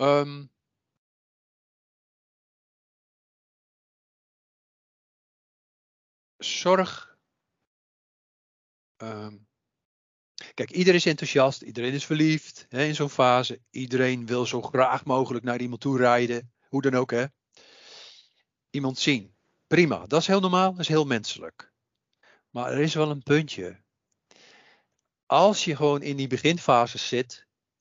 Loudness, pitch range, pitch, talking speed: -24 LUFS, 120-150 Hz, 130 Hz, 110 wpm